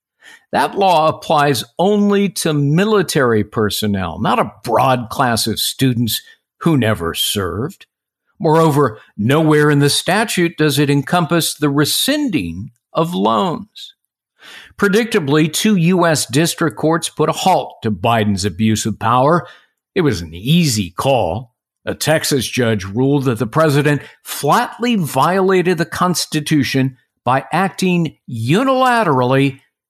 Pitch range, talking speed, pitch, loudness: 125-175 Hz, 120 wpm, 150 Hz, -15 LUFS